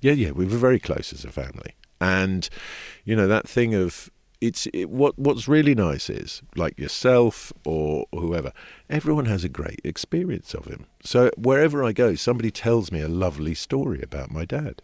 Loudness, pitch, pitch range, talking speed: -23 LUFS, 100 Hz, 80-125 Hz, 185 wpm